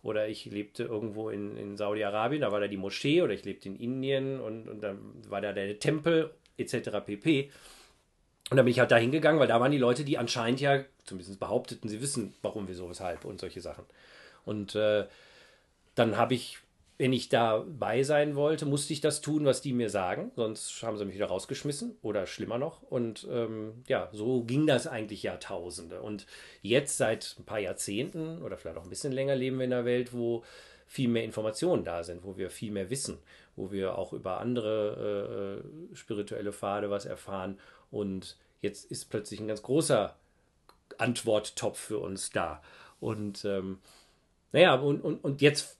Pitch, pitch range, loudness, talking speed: 110 Hz, 100-135 Hz, -31 LUFS, 185 wpm